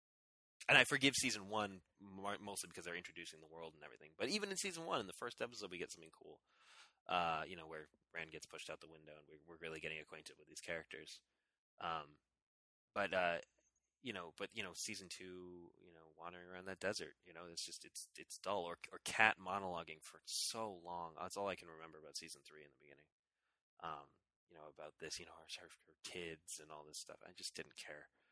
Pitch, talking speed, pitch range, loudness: 85 Hz, 220 wpm, 80-100 Hz, -43 LUFS